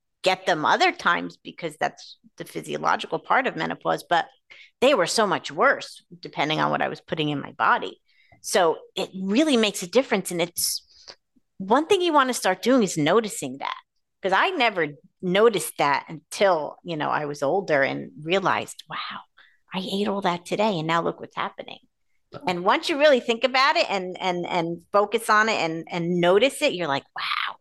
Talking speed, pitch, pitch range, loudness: 190 wpm, 195 Hz, 175-235 Hz, -23 LUFS